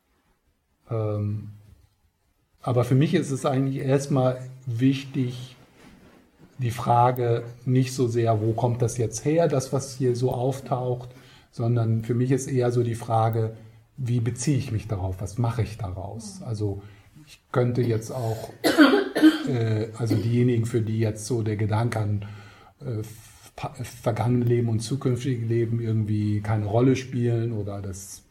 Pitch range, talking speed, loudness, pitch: 110-130 Hz, 145 wpm, -25 LUFS, 120 Hz